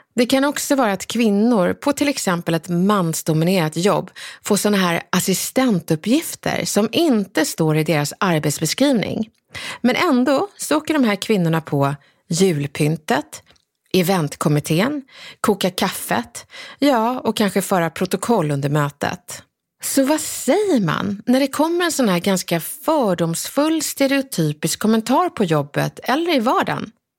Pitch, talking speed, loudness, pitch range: 200 Hz, 130 wpm, -19 LUFS, 165-270 Hz